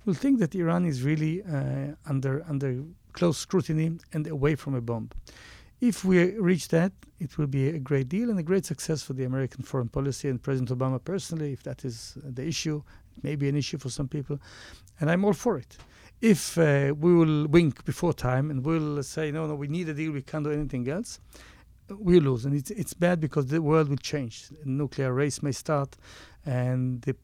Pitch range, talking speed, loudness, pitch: 135-165 Hz, 205 wpm, -27 LUFS, 145 Hz